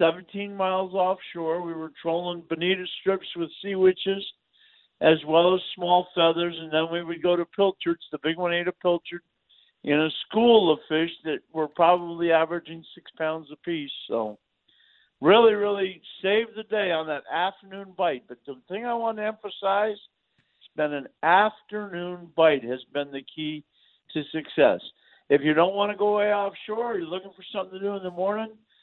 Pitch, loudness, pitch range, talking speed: 175 Hz, -25 LUFS, 160-195 Hz, 180 wpm